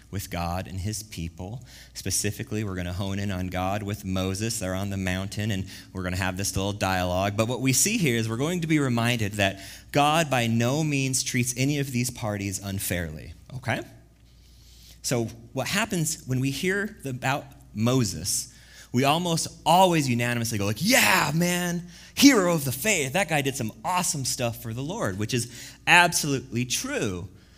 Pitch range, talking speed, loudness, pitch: 95-140 Hz, 180 wpm, -25 LUFS, 115 Hz